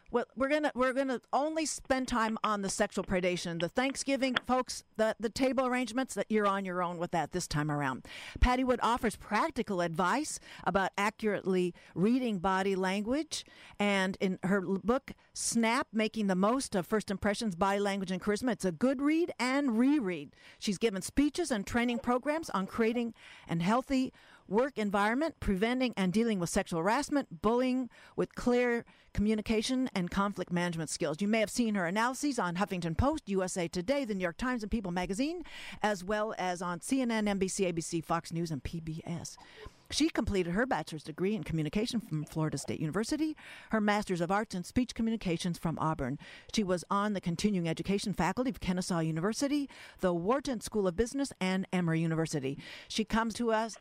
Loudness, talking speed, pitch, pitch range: -32 LUFS, 175 wpm, 210 Hz, 180-250 Hz